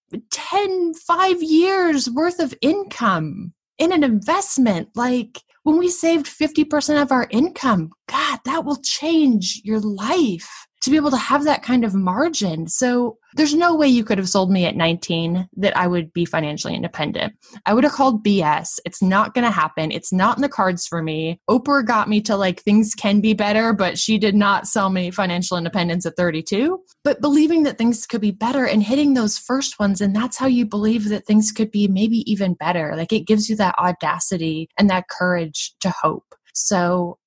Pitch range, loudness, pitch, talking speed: 185-280 Hz, -19 LUFS, 215 Hz, 195 wpm